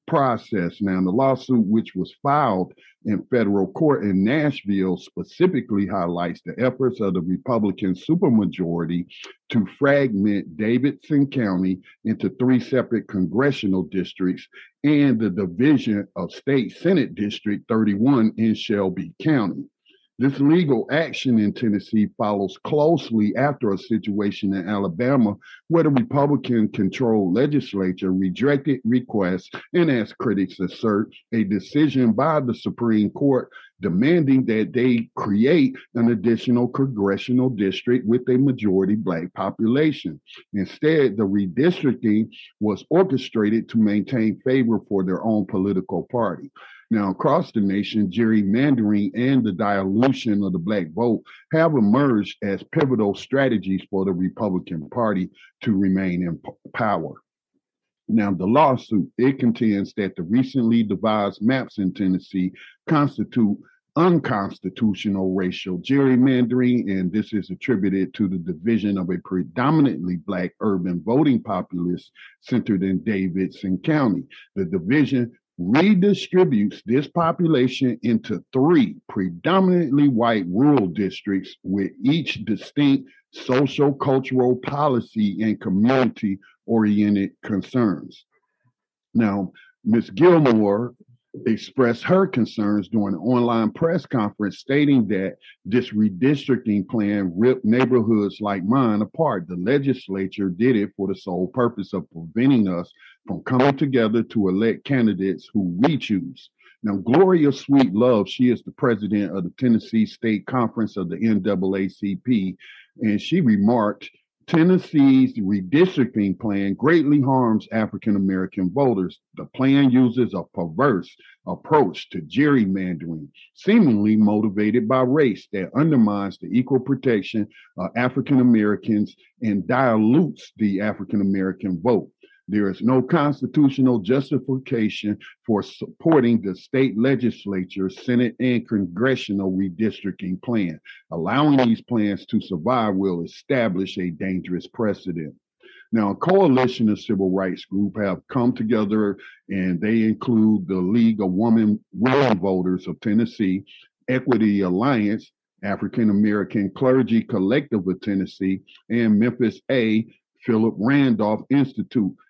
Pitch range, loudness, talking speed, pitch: 100-130 Hz, -21 LUFS, 120 wpm, 110 Hz